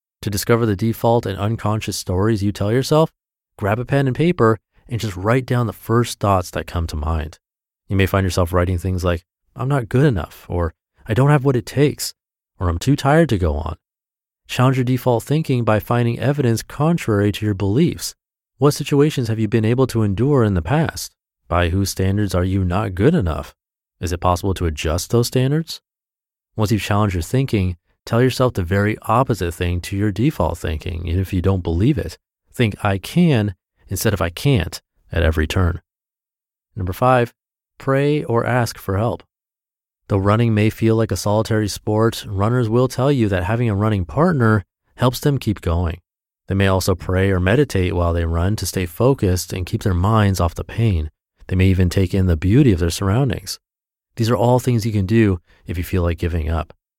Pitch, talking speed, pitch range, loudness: 105 Hz, 200 wpm, 90-120 Hz, -19 LUFS